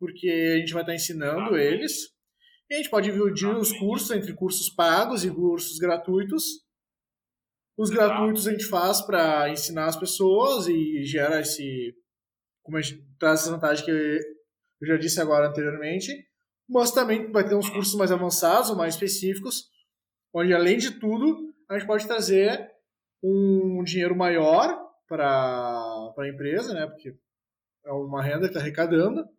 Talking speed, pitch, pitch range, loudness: 155 wpm, 180 Hz, 155-215 Hz, -24 LUFS